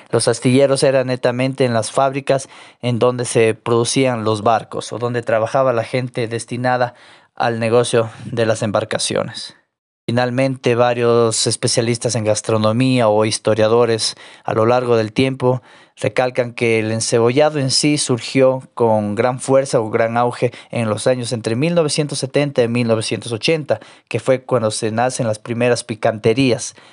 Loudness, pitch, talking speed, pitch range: -17 LUFS, 120 Hz, 145 wpm, 115-130 Hz